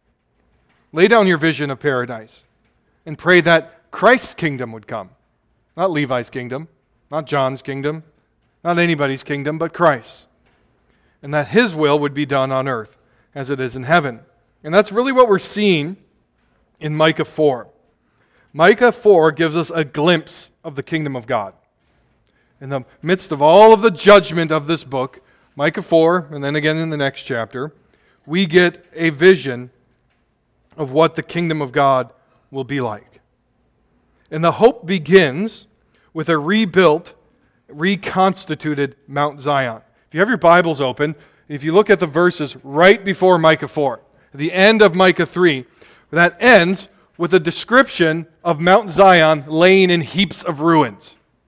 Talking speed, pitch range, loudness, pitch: 155 wpm, 140-180 Hz, -16 LUFS, 160 Hz